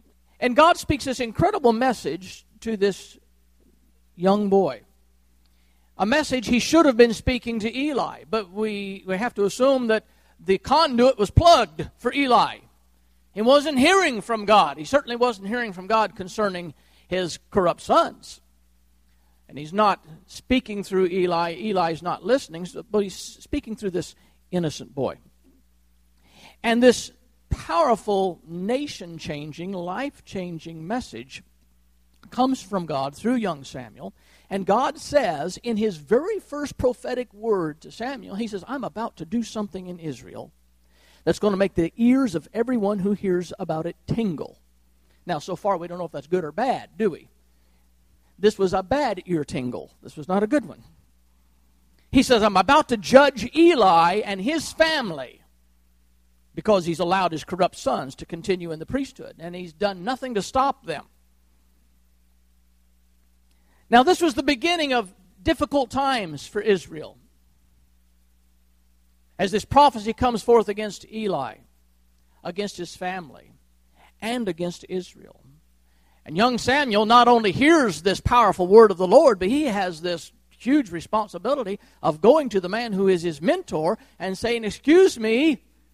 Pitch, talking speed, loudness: 190 Hz, 150 wpm, -22 LUFS